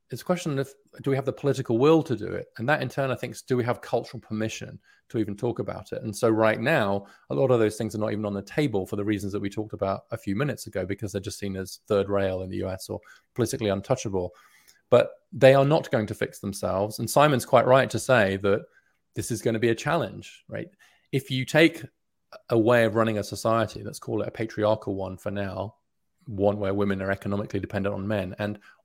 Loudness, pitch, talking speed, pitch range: -26 LUFS, 110 Hz, 245 wpm, 100-125 Hz